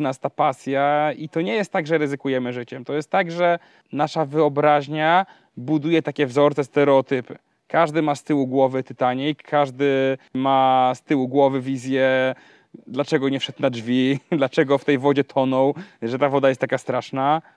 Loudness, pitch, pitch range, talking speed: -21 LUFS, 140 Hz, 135-150 Hz, 165 wpm